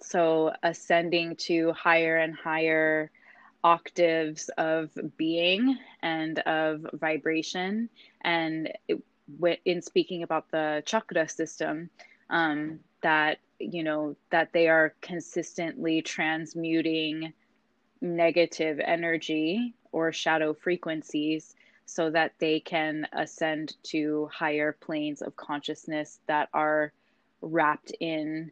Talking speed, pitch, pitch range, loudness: 100 wpm, 160 Hz, 155-170 Hz, -28 LUFS